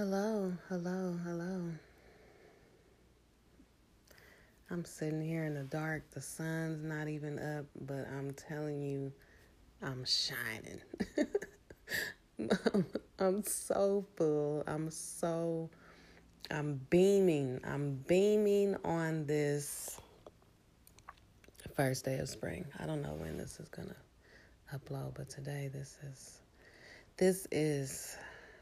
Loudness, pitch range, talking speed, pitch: -37 LUFS, 140-175 Hz, 105 wpm, 155 Hz